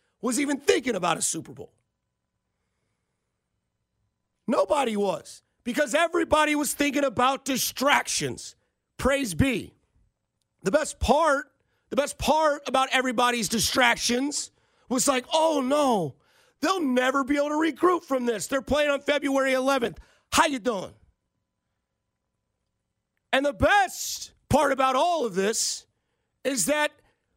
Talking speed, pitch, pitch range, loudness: 125 wpm, 275 Hz, 245-295 Hz, -24 LUFS